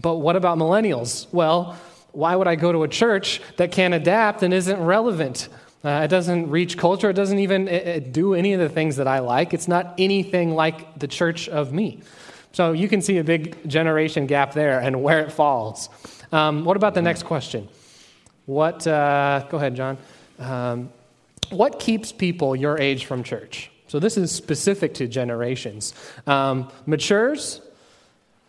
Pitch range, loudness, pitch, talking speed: 140-180 Hz, -21 LUFS, 160 Hz, 175 wpm